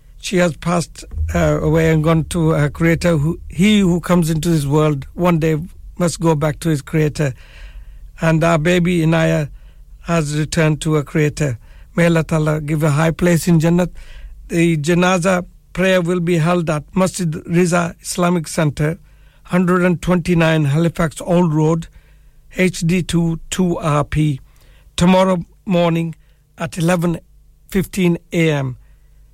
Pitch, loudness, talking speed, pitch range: 165 Hz, -17 LUFS, 130 wpm, 155-175 Hz